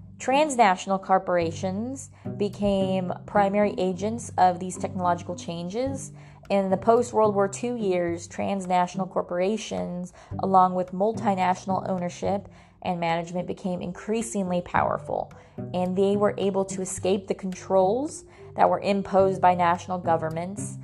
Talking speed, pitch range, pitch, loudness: 120 wpm, 180-200 Hz, 190 Hz, -25 LUFS